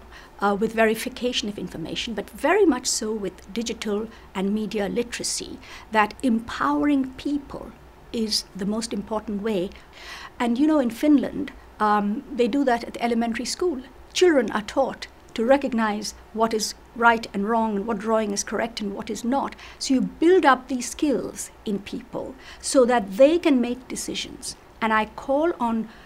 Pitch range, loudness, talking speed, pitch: 215-265 Hz, -24 LUFS, 165 wpm, 235 Hz